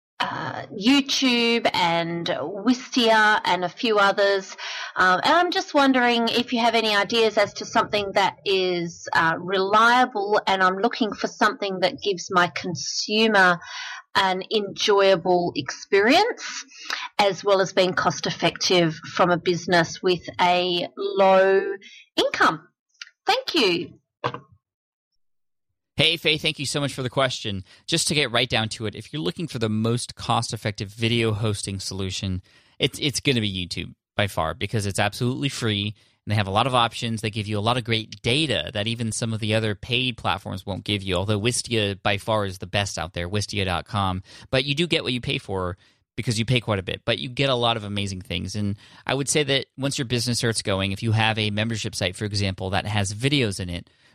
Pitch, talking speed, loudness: 135 Hz, 190 wpm, -22 LUFS